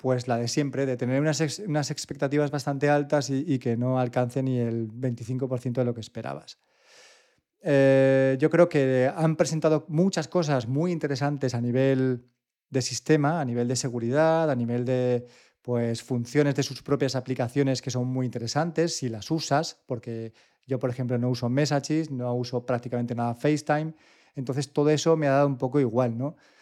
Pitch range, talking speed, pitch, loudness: 125-150 Hz, 180 wpm, 135 Hz, -26 LUFS